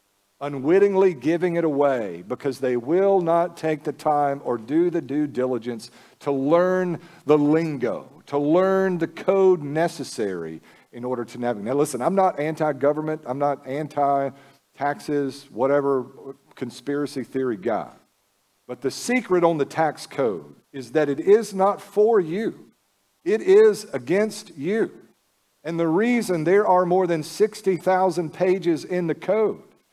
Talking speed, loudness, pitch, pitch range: 145 wpm, -22 LUFS, 155 Hz, 135-180 Hz